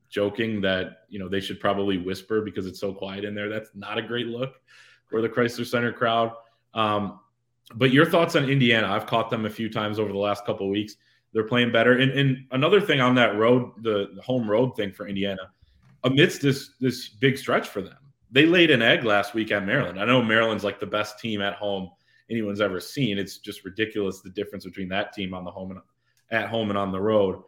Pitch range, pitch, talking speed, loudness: 100-120 Hz, 110 Hz, 225 wpm, -24 LUFS